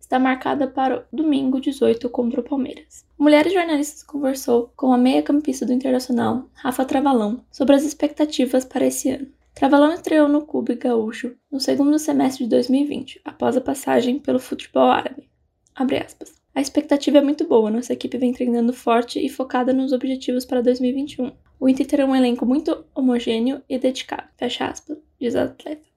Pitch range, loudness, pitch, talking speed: 250-290 Hz, -20 LUFS, 265 Hz, 170 wpm